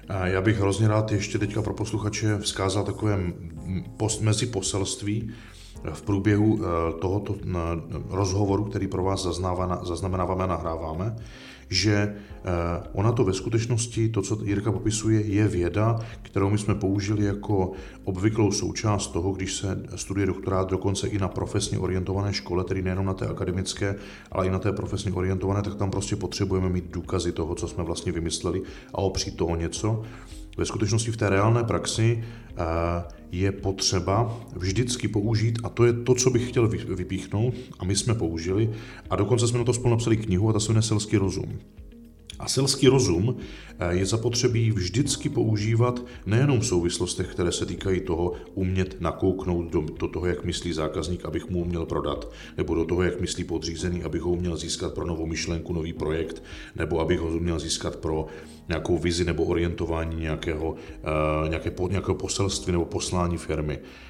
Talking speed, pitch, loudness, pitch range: 160 wpm, 95 Hz, -26 LUFS, 85-110 Hz